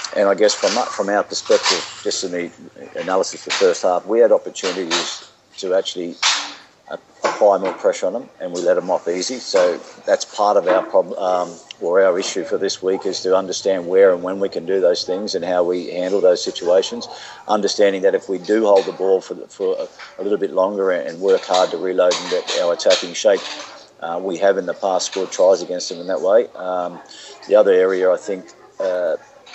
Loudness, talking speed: -18 LUFS, 215 wpm